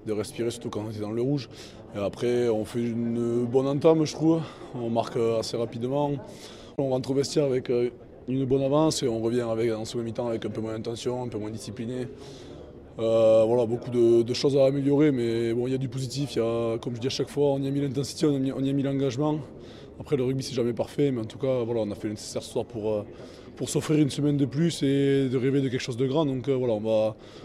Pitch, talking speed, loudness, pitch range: 125 Hz, 260 wpm, -26 LUFS, 115-140 Hz